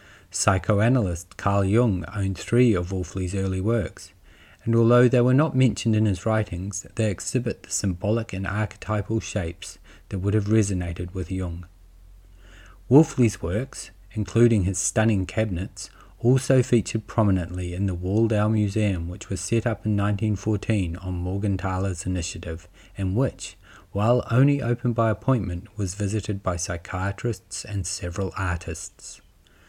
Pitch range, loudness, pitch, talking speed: 90-110 Hz, -24 LUFS, 100 Hz, 135 wpm